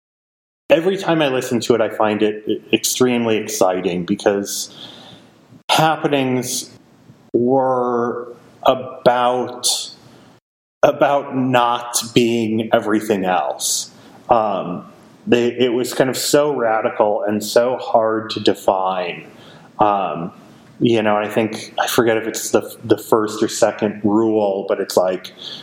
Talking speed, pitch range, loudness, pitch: 125 wpm, 110-125 Hz, -18 LUFS, 120 Hz